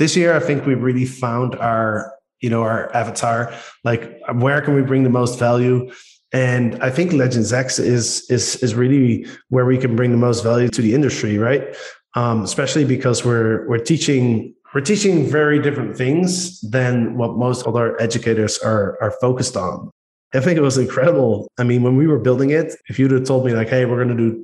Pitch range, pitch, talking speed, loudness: 120-135 Hz, 125 Hz, 205 wpm, -18 LUFS